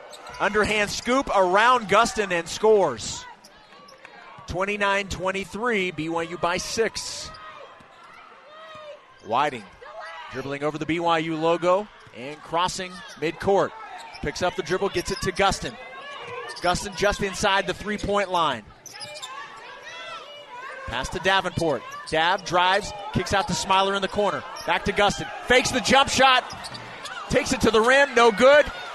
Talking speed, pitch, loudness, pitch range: 125 wpm, 195 Hz, -22 LUFS, 180-225 Hz